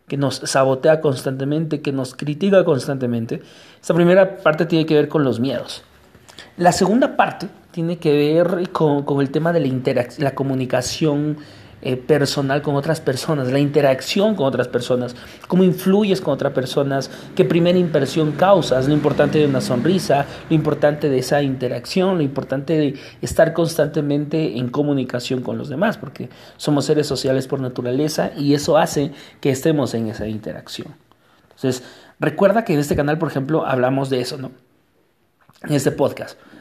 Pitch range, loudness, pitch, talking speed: 130-160 Hz, -19 LUFS, 145 Hz, 165 wpm